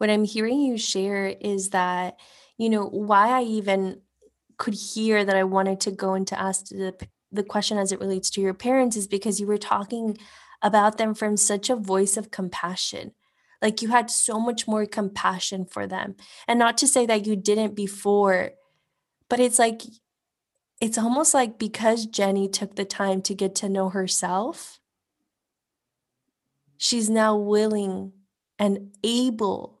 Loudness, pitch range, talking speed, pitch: -23 LUFS, 195-225 Hz, 165 wpm, 210 Hz